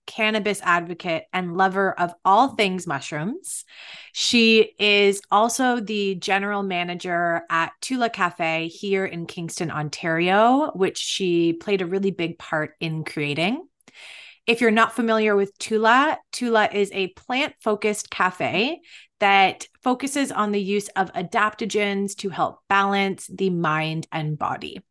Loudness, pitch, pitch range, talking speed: -22 LUFS, 195 Hz, 175-220 Hz, 135 wpm